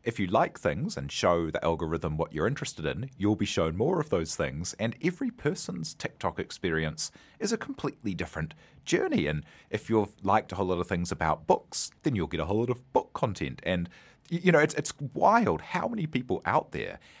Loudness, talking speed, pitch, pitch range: -29 LUFS, 210 wpm, 100 Hz, 85-125 Hz